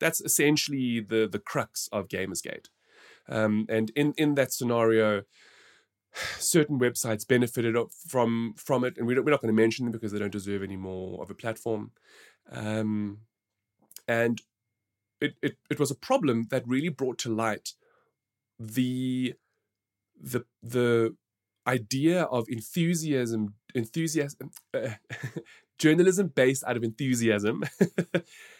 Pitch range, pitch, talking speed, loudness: 110-140 Hz, 120 Hz, 130 wpm, -28 LUFS